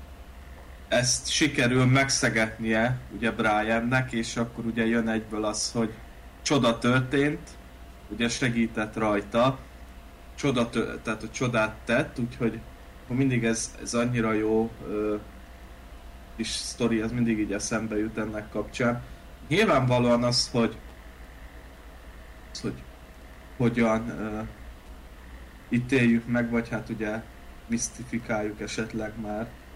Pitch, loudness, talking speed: 110 Hz, -27 LUFS, 105 wpm